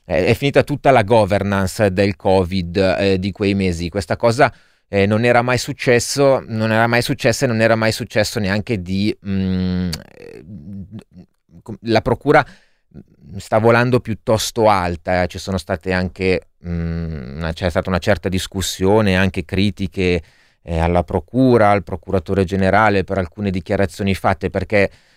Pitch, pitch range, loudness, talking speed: 100 Hz, 95-110 Hz, -17 LUFS, 140 wpm